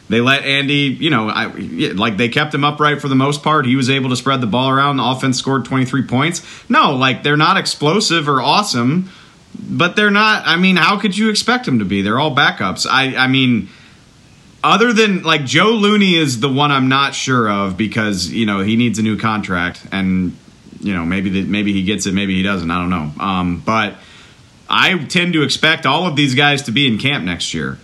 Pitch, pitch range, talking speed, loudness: 135 Hz, 105-155 Hz, 225 wpm, -14 LUFS